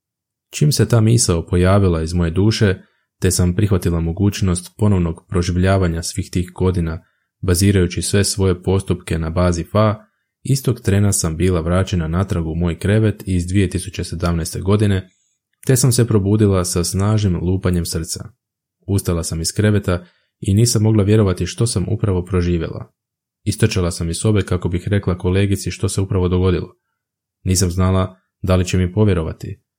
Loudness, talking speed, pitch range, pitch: -18 LUFS, 150 wpm, 90-105 Hz, 95 Hz